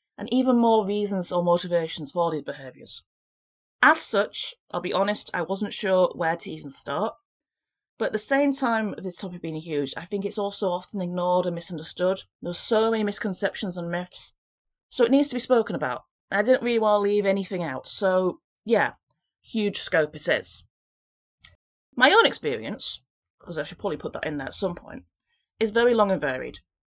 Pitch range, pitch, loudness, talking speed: 175-220 Hz, 195 Hz, -25 LUFS, 190 wpm